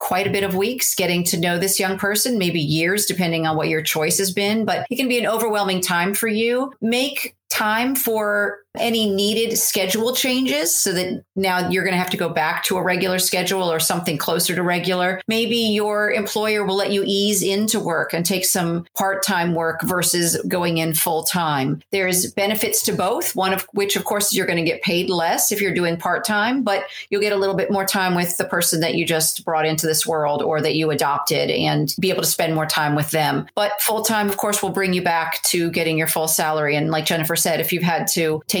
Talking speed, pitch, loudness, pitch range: 230 wpm, 185 Hz, -19 LUFS, 170-210 Hz